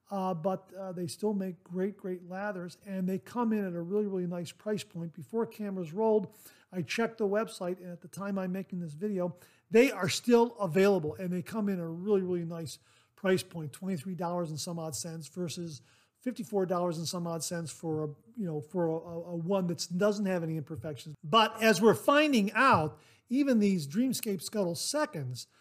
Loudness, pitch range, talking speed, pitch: -31 LUFS, 170-205 Hz, 195 wpm, 185 Hz